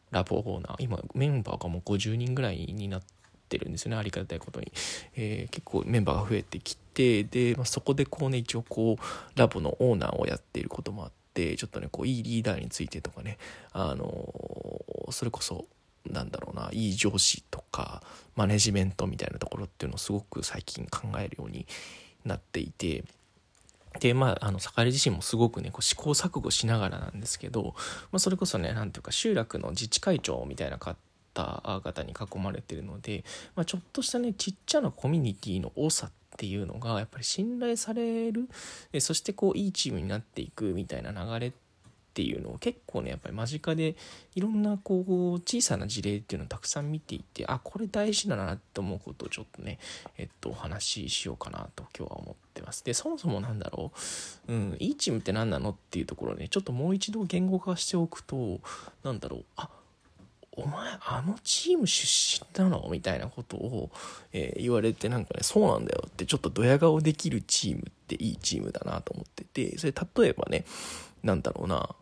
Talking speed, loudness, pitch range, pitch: 400 characters per minute, -31 LUFS, 100-170 Hz, 120 Hz